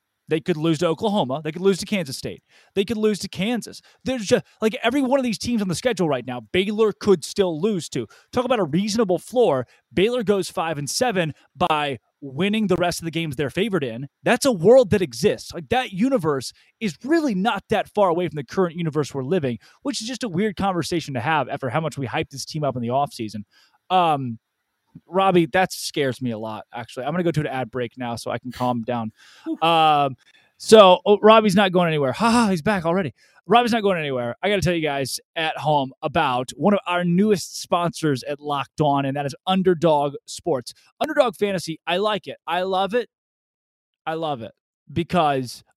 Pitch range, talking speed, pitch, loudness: 140-205 Hz, 215 wpm, 170 Hz, -21 LUFS